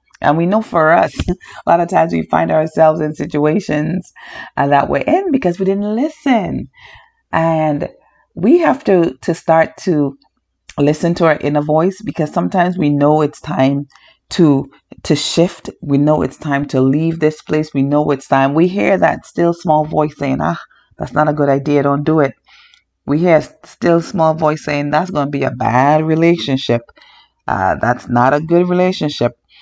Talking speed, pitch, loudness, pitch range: 185 wpm, 155 Hz, -15 LUFS, 145-175 Hz